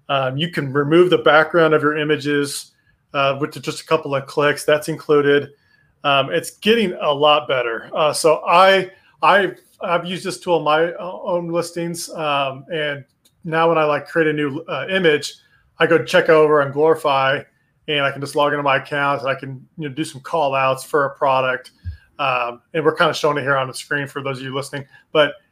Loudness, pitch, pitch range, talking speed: -18 LUFS, 150 Hz, 140-160 Hz, 215 wpm